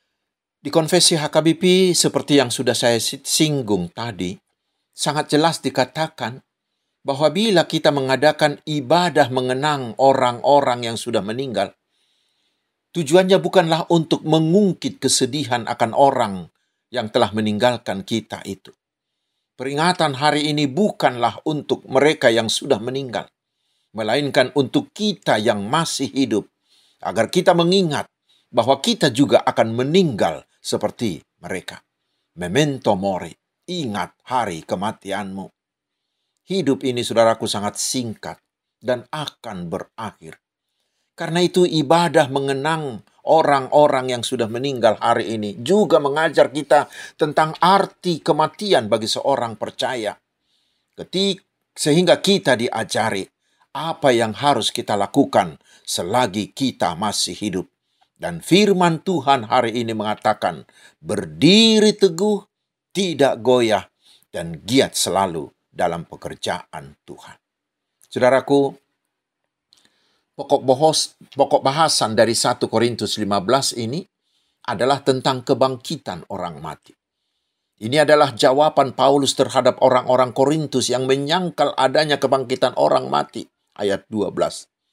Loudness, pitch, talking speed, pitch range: -19 LUFS, 140 Hz, 105 wpm, 120-160 Hz